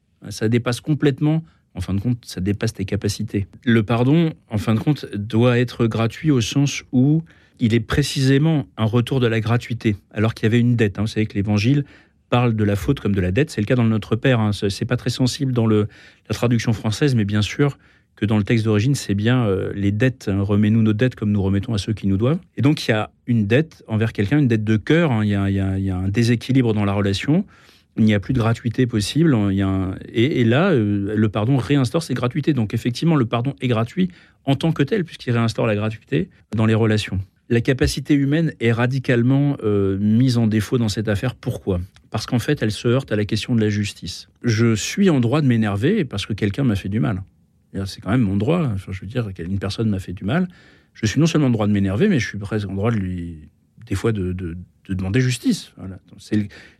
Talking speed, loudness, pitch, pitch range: 245 wpm, -20 LUFS, 115 Hz, 105-130 Hz